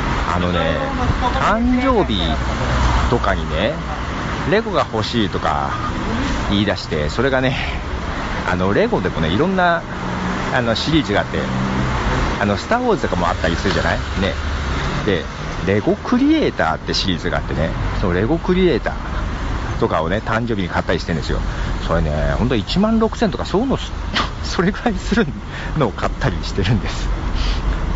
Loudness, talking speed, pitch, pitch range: -19 LUFS, 325 characters per minute, 85 Hz, 70-105 Hz